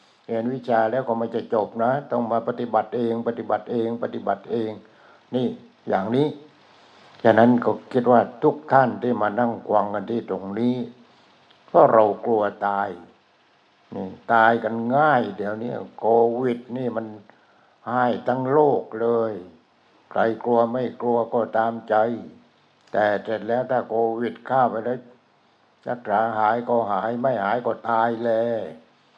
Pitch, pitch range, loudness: 115 Hz, 115-120 Hz, -22 LUFS